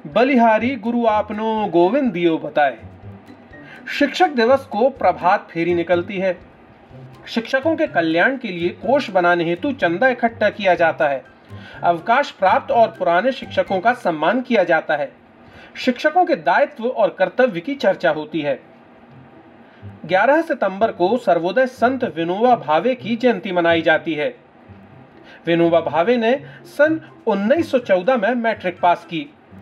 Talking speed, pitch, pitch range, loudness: 130 wpm, 210 Hz, 170-255 Hz, -18 LUFS